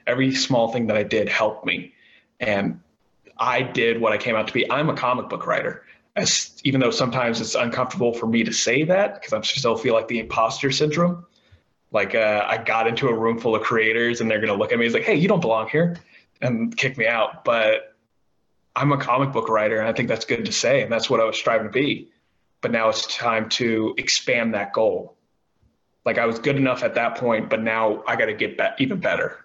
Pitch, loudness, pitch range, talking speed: 120 Hz, -21 LUFS, 115-140 Hz, 230 wpm